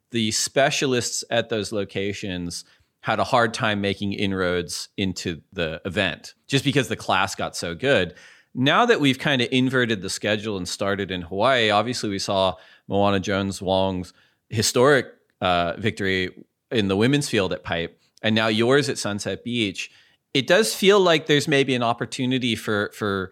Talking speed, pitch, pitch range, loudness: 165 wpm, 105 Hz, 95-125 Hz, -22 LUFS